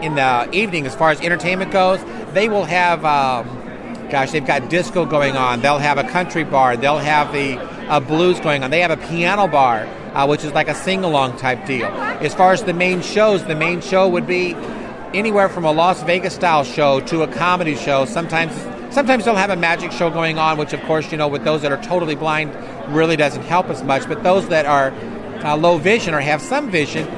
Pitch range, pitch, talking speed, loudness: 145-180 Hz, 160 Hz, 215 wpm, -17 LUFS